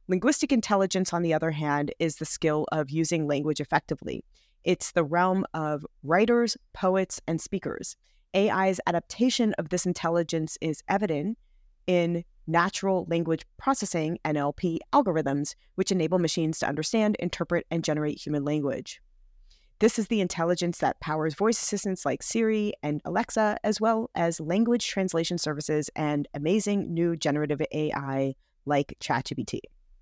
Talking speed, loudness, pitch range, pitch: 140 wpm, -27 LUFS, 155-195 Hz, 170 Hz